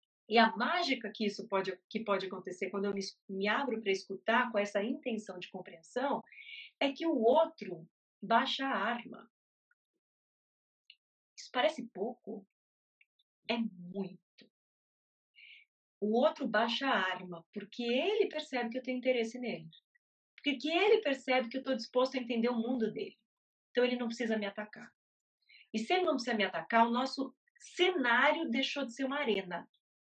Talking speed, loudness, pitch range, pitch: 155 wpm, -33 LUFS, 205-270 Hz, 235 Hz